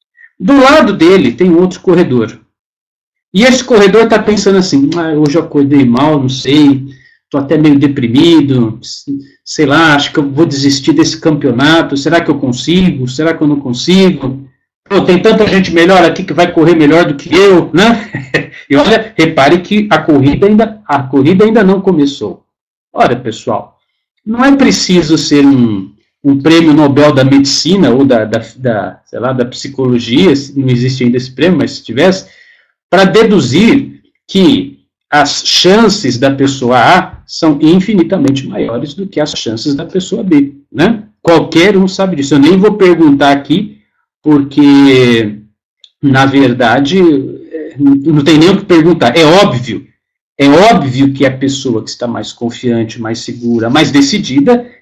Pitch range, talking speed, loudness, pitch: 135-185 Hz, 165 wpm, -8 LUFS, 155 Hz